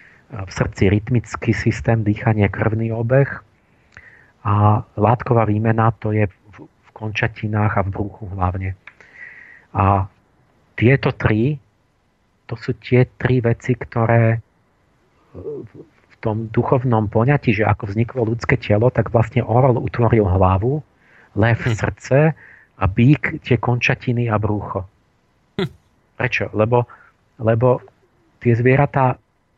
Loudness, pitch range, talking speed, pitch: -18 LUFS, 105-125 Hz, 110 wpm, 115 Hz